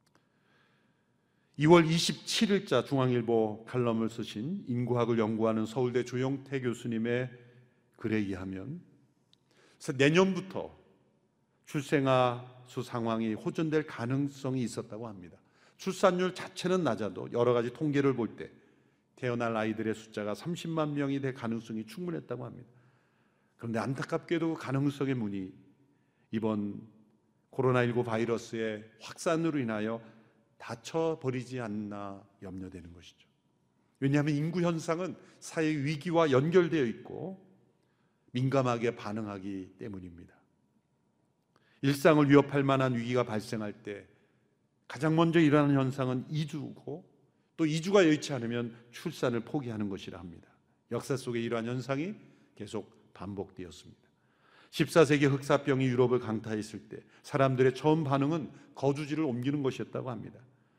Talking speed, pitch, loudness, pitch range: 285 characters per minute, 125 Hz, -31 LUFS, 110-150 Hz